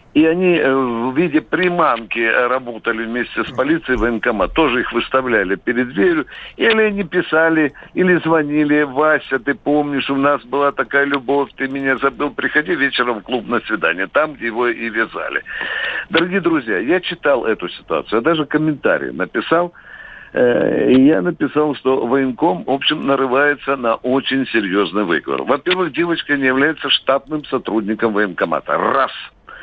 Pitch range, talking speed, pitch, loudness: 125-155 Hz, 150 wpm, 140 Hz, -17 LUFS